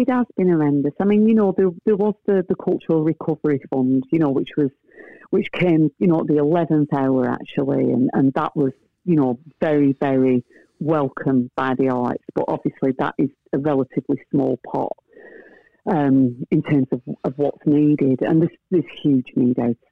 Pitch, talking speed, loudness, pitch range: 150 Hz, 185 wpm, -20 LUFS, 135-180 Hz